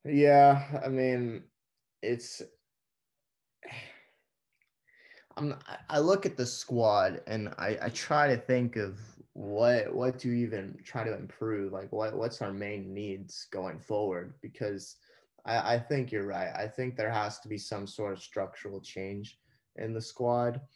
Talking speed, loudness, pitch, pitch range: 155 wpm, -31 LUFS, 120 Hz, 105-135 Hz